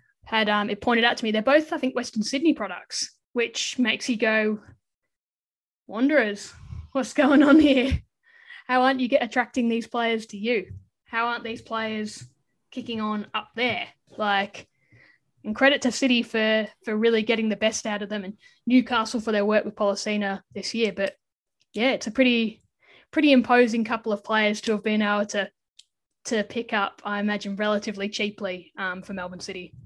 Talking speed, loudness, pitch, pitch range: 180 wpm, -24 LUFS, 220 Hz, 205-245 Hz